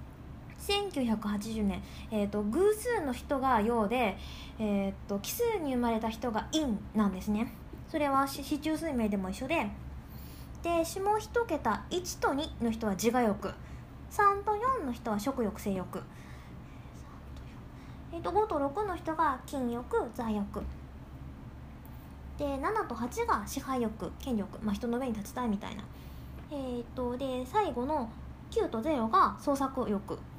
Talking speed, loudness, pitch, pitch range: 205 characters per minute, -32 LUFS, 240 Hz, 210-295 Hz